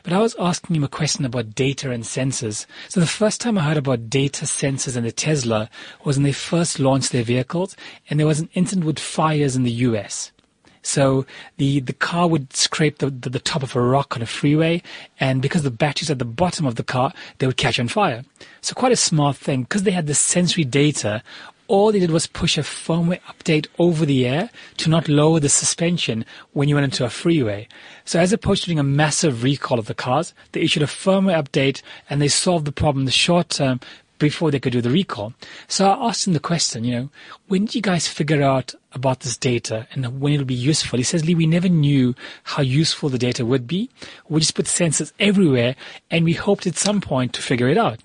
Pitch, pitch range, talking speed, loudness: 150 Hz, 130-170 Hz, 230 wpm, -20 LUFS